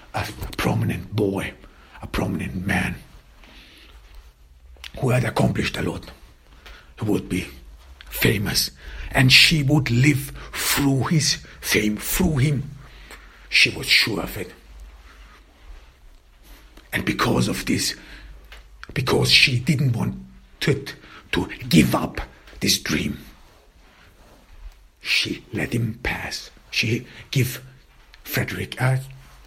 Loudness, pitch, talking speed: -21 LUFS, 95 Hz, 105 wpm